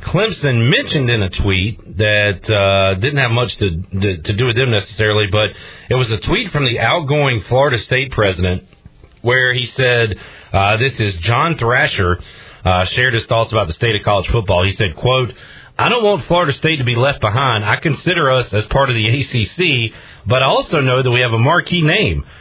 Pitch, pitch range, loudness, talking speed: 120 Hz, 105-135 Hz, -15 LUFS, 200 wpm